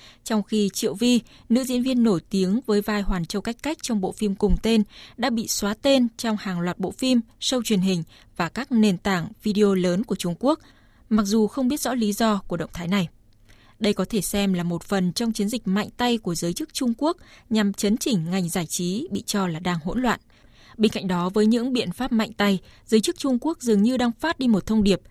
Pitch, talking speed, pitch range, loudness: 210 Hz, 245 wpm, 190-235 Hz, -23 LUFS